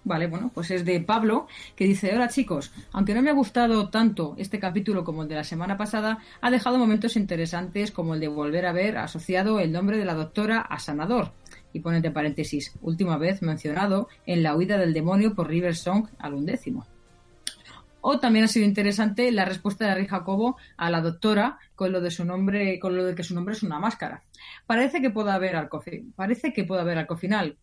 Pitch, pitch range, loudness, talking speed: 190 Hz, 170-220 Hz, -25 LUFS, 200 wpm